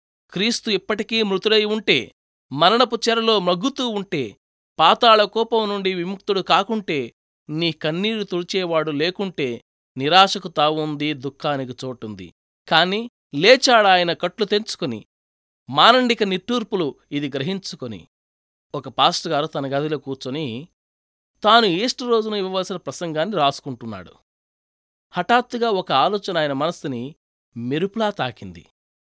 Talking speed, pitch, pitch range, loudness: 100 wpm, 175 Hz, 140-215 Hz, -19 LUFS